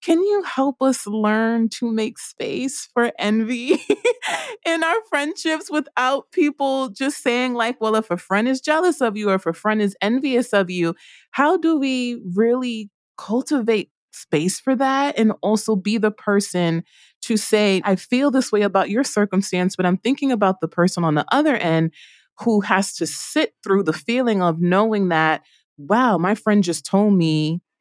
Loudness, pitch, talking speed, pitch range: -20 LUFS, 220 Hz, 175 wpm, 190-265 Hz